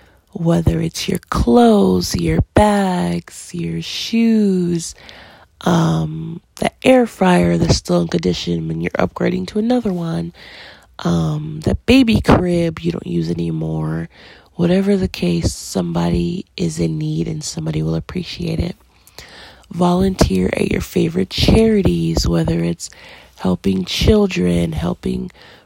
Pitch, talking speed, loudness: 155 Hz, 120 wpm, -17 LUFS